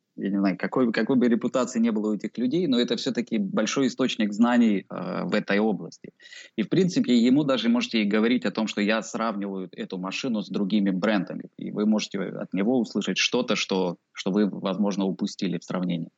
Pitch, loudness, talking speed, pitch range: 110 Hz, -25 LUFS, 195 wpm, 100-125 Hz